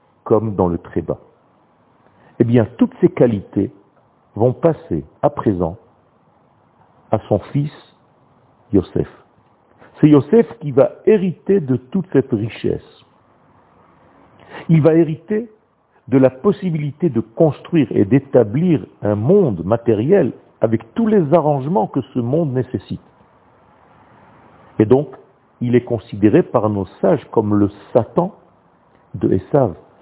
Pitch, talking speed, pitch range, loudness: 135 Hz, 120 wpm, 115-165 Hz, -17 LUFS